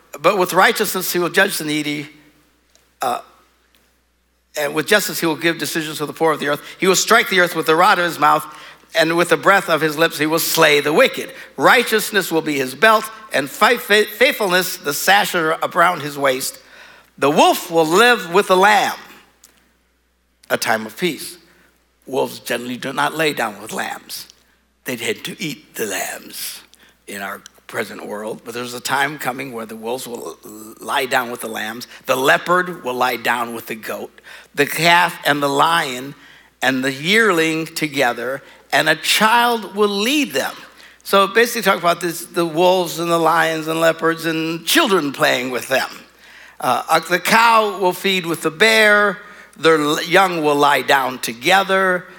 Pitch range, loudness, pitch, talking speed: 145-190 Hz, -16 LUFS, 165 Hz, 175 wpm